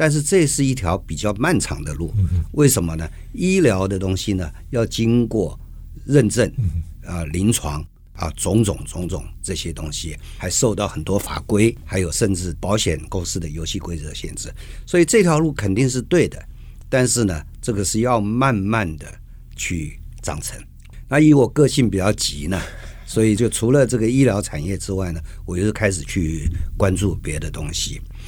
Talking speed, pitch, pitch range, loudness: 255 characters per minute, 95 Hz, 80-115 Hz, -20 LUFS